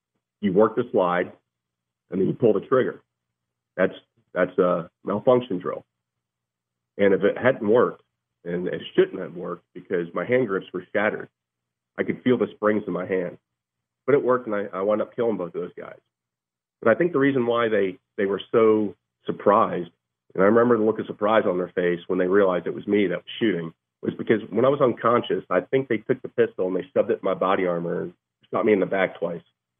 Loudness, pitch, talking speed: -23 LUFS, 90 Hz, 220 wpm